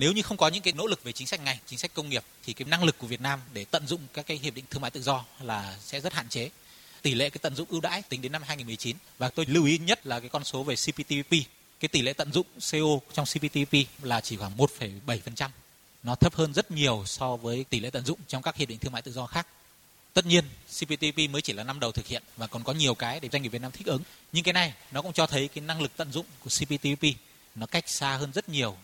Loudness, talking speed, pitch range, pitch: -29 LUFS, 280 wpm, 125-160 Hz, 140 Hz